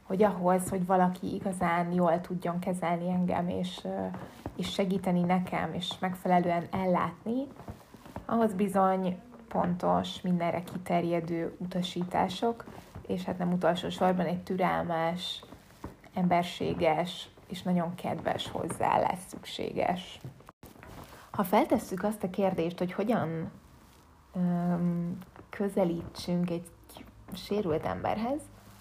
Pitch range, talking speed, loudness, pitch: 170-195 Hz, 100 wpm, -31 LUFS, 180 Hz